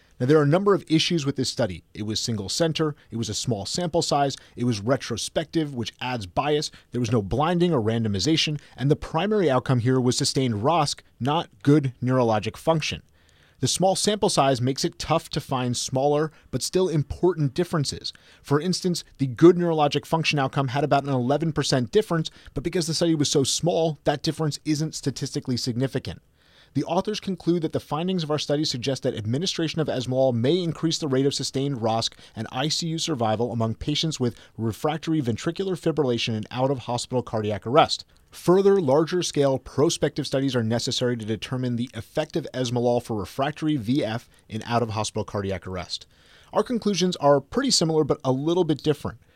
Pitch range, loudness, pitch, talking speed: 120-160 Hz, -24 LUFS, 140 Hz, 175 wpm